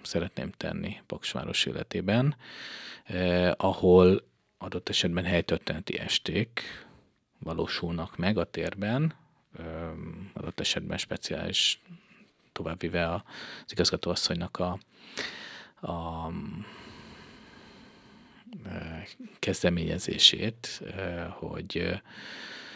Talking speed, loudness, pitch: 70 wpm, -29 LUFS, 90 Hz